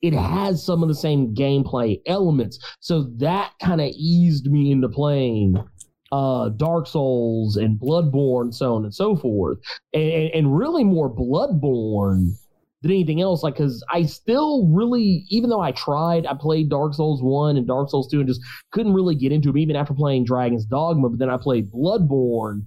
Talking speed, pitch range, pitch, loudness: 185 wpm, 125-165 Hz, 145 Hz, -20 LUFS